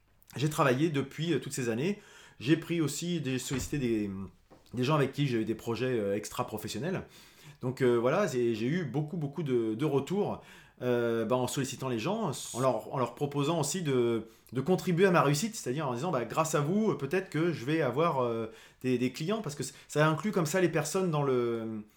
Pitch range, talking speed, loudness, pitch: 120-165 Hz, 210 wpm, -31 LUFS, 140 Hz